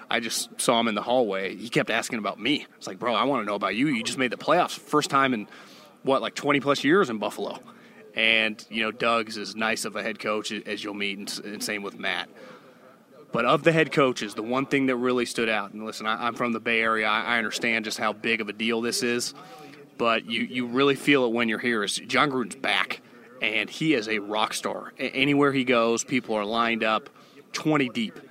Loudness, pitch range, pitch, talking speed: -25 LUFS, 110-130 Hz, 115 Hz, 240 wpm